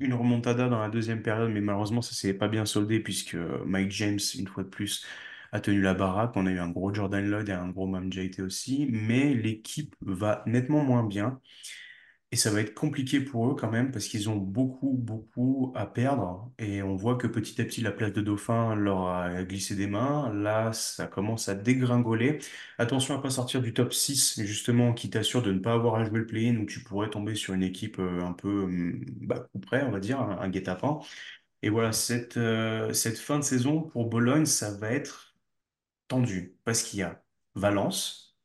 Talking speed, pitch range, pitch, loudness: 210 wpm, 100-120 Hz, 110 Hz, -29 LUFS